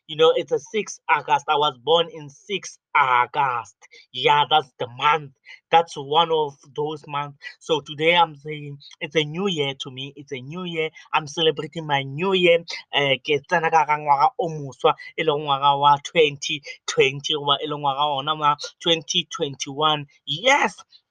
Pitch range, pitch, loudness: 145-170 Hz, 155 Hz, -21 LUFS